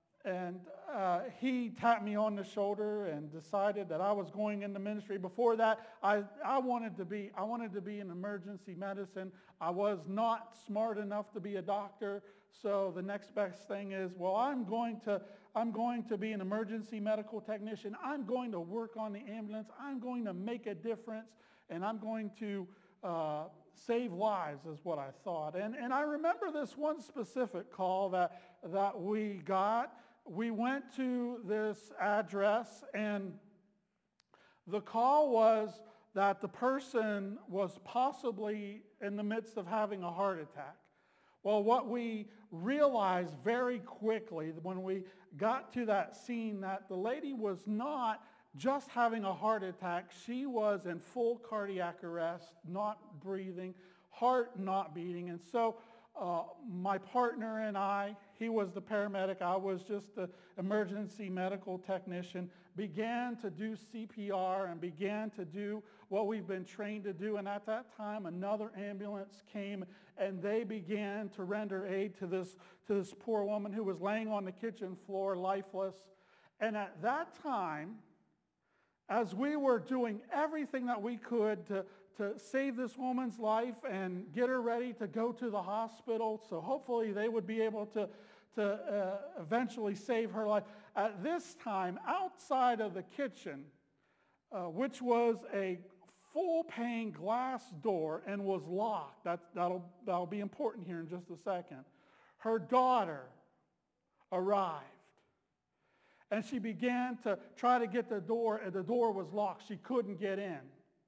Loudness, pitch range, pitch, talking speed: -38 LUFS, 195-230 Hz, 210 Hz, 160 wpm